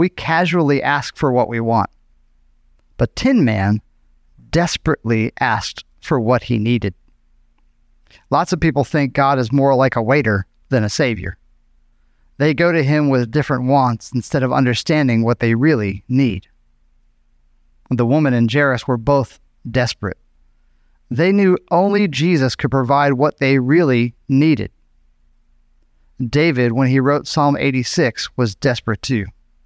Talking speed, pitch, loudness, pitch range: 140 wpm, 125 Hz, -17 LUFS, 95-145 Hz